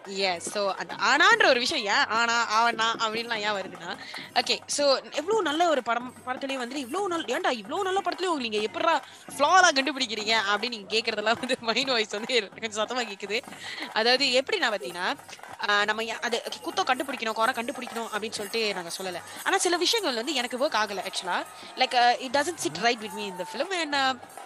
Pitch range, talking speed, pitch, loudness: 220-290 Hz, 60 wpm, 240 Hz, -26 LUFS